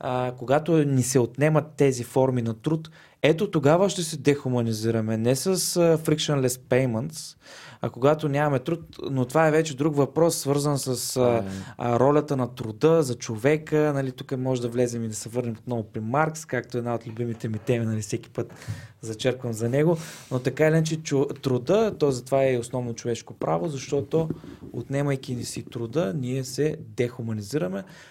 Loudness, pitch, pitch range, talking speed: -25 LUFS, 135 Hz, 120-155 Hz, 175 wpm